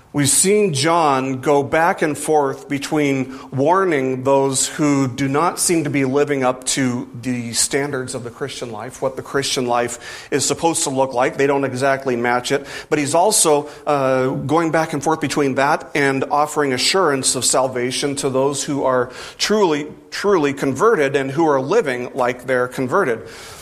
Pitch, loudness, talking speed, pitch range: 140 Hz, -18 LUFS, 175 wpm, 130-145 Hz